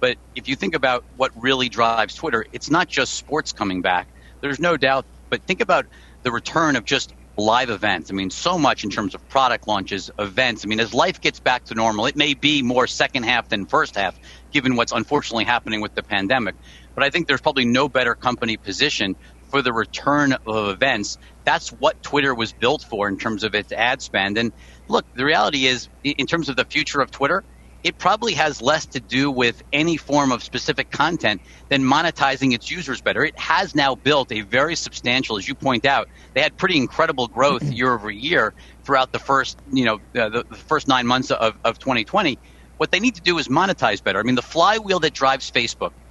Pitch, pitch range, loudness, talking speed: 125 Hz, 105-140 Hz, -20 LUFS, 210 wpm